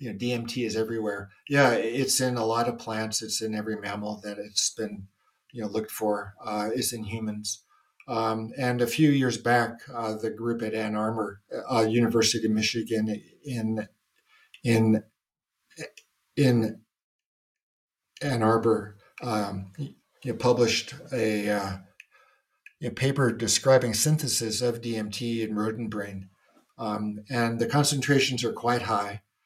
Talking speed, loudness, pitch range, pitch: 145 wpm, -27 LUFS, 105-120 Hz, 110 Hz